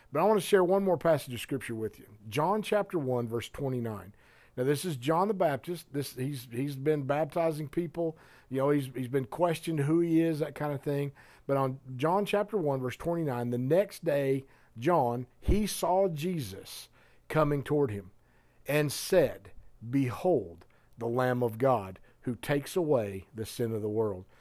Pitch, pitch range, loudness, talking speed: 140 Hz, 125-165 Hz, -30 LUFS, 180 wpm